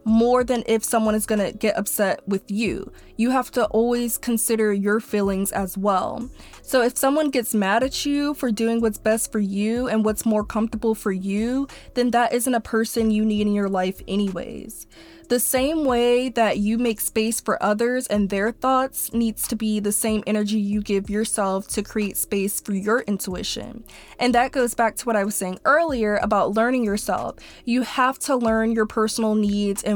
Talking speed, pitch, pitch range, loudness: 195 wpm, 225 Hz, 210-240 Hz, -22 LUFS